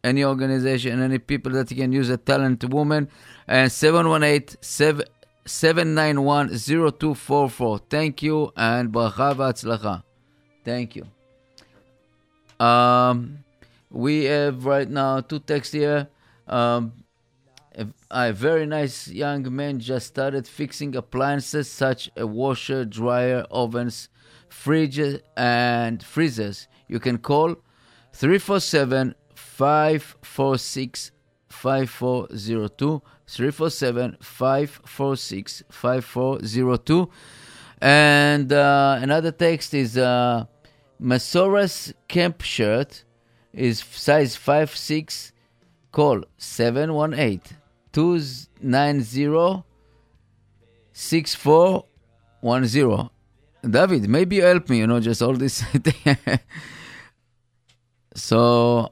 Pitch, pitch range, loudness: 130 Hz, 120-145 Hz, -21 LUFS